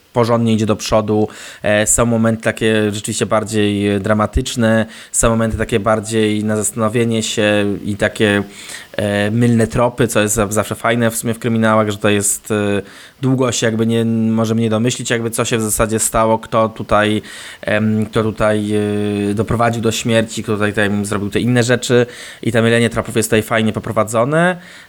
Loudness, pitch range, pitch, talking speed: -16 LUFS, 105-115 Hz, 110 Hz, 160 wpm